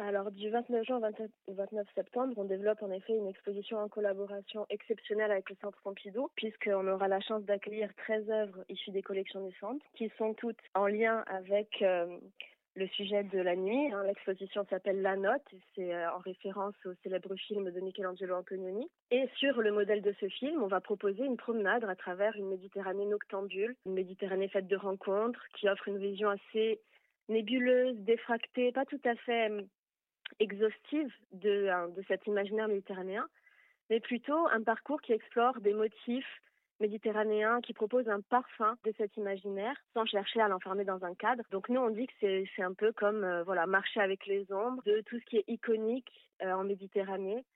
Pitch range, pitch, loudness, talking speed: 195-225 Hz, 205 Hz, -35 LUFS, 185 wpm